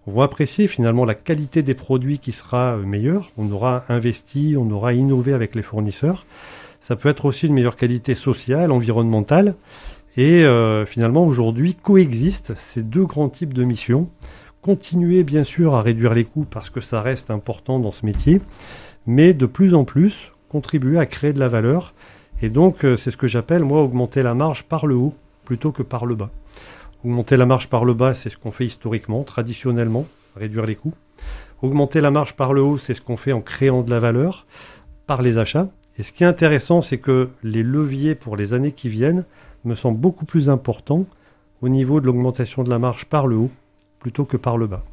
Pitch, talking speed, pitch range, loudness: 130 Hz, 200 wpm, 120-150 Hz, -19 LUFS